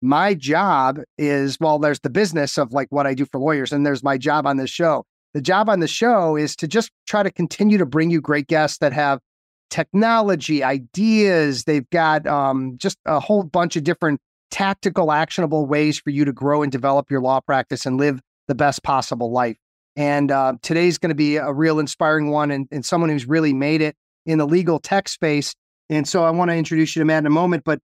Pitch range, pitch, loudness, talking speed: 140-165 Hz, 150 Hz, -19 LUFS, 220 wpm